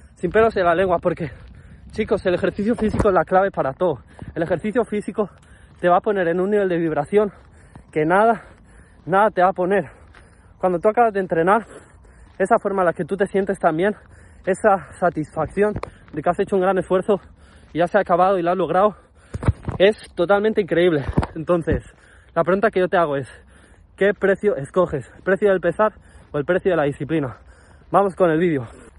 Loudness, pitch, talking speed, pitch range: -20 LUFS, 180 Hz, 195 wpm, 160-200 Hz